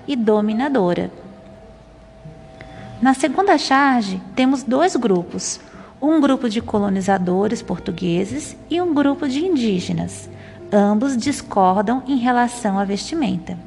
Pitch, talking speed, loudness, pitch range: 230 Hz, 105 wpm, -19 LUFS, 195-275 Hz